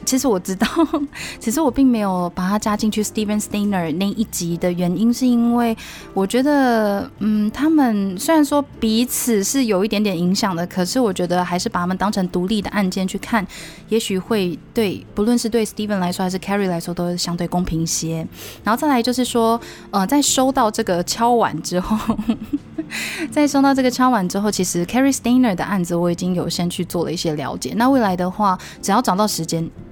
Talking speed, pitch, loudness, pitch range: 360 characters per minute, 210 Hz, -19 LUFS, 180-235 Hz